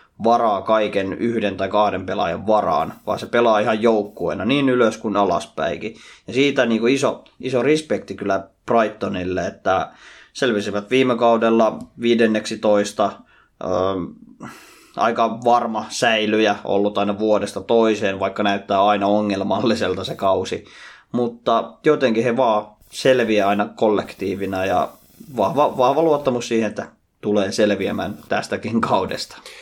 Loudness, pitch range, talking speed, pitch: -20 LUFS, 100-115 Hz, 125 wpm, 105 Hz